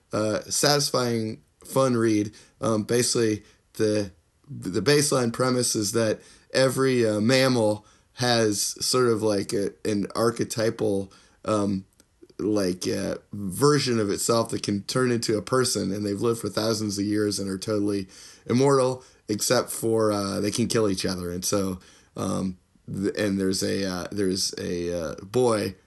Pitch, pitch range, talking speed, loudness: 105 Hz, 100-120 Hz, 155 wpm, -25 LUFS